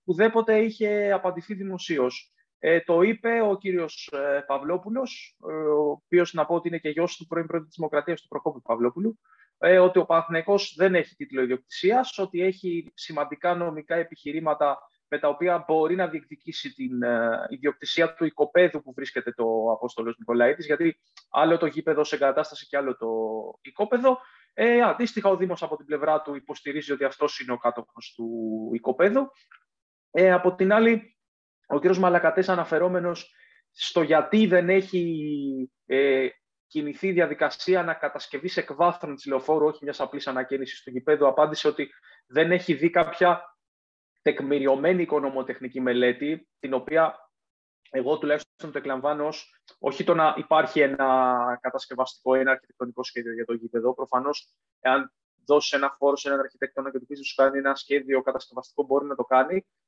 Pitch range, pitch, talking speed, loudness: 135-175 Hz, 150 Hz, 155 wpm, -25 LUFS